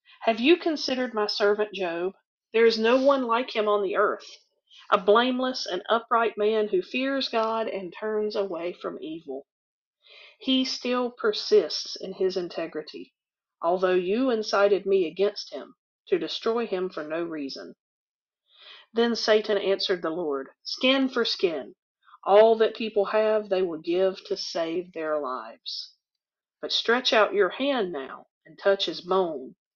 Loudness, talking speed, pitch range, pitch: -25 LUFS, 150 wpm, 185-245 Hz, 210 Hz